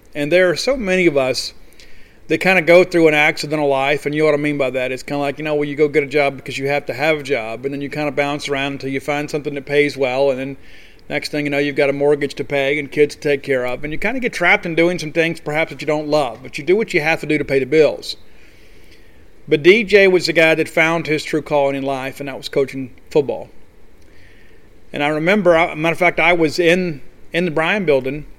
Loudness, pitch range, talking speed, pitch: -17 LUFS, 135-160 Hz, 280 wpm, 145 Hz